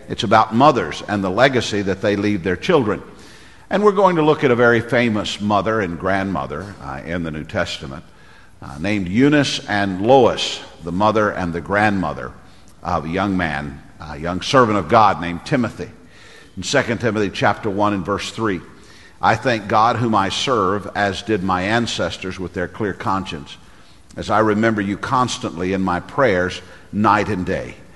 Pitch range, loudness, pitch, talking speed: 90-110 Hz, -18 LUFS, 100 Hz, 175 wpm